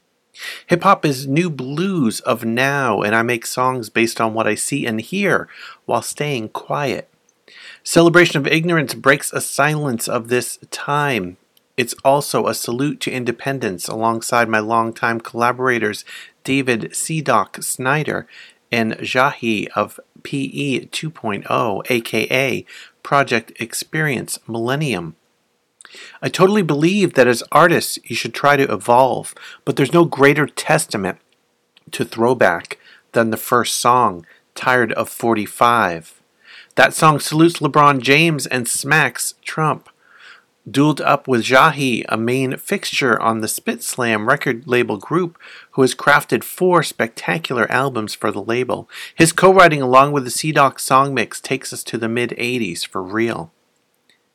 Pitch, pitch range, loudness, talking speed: 130 Hz, 115-150 Hz, -17 LUFS, 140 wpm